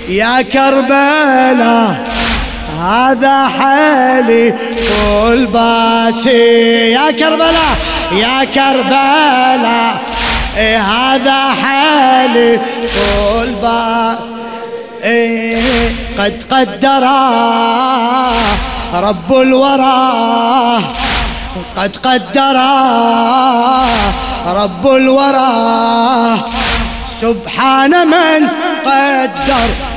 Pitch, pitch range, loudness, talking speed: 250 Hz, 230-270 Hz, -10 LUFS, 45 wpm